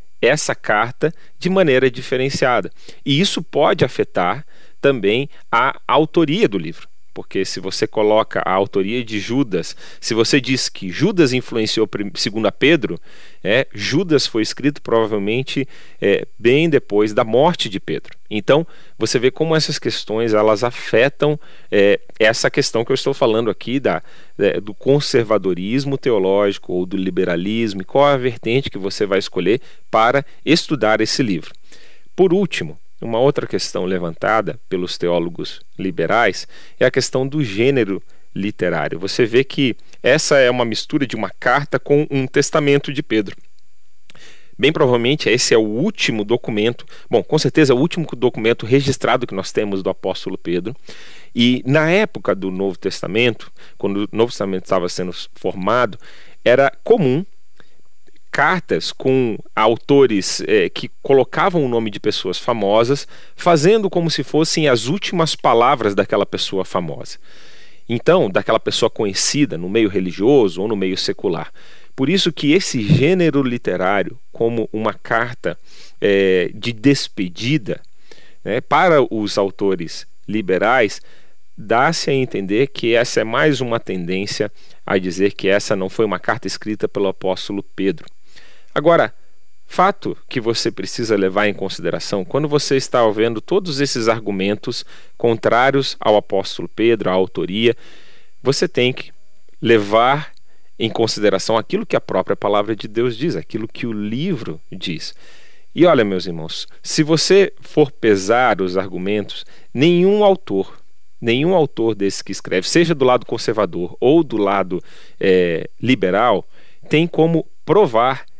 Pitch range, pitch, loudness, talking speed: 100-140 Hz, 115 Hz, -17 LUFS, 145 wpm